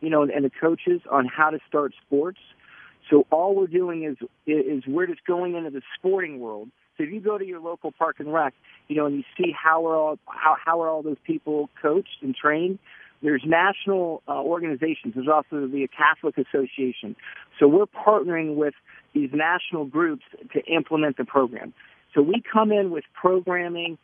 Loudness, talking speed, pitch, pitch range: -24 LUFS, 190 wpm, 160 Hz, 150-185 Hz